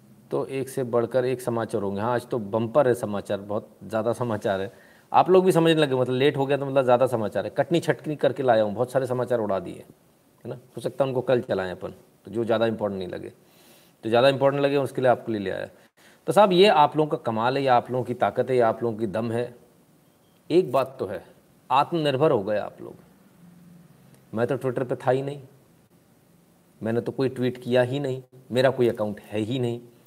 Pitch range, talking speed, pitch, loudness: 115-140 Hz, 230 wpm, 125 Hz, -24 LUFS